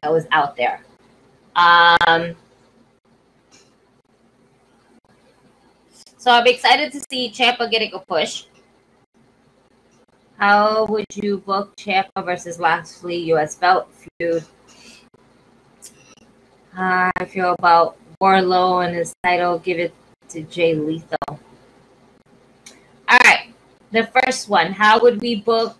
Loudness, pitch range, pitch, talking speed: -17 LUFS, 165-215 Hz, 180 Hz, 105 wpm